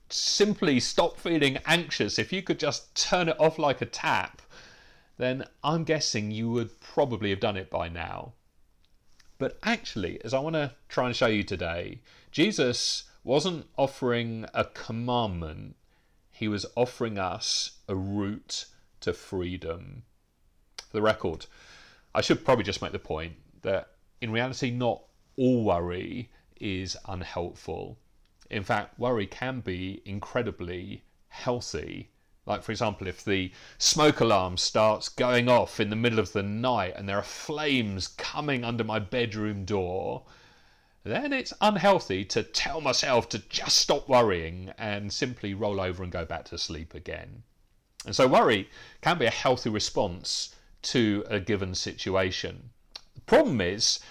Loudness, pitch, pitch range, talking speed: -28 LUFS, 110 Hz, 95-125 Hz, 150 wpm